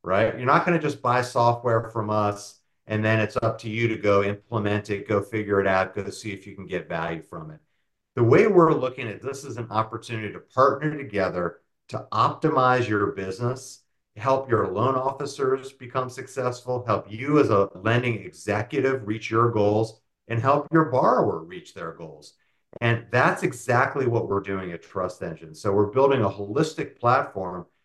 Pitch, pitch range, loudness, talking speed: 110 Hz, 100-130 Hz, -24 LUFS, 185 wpm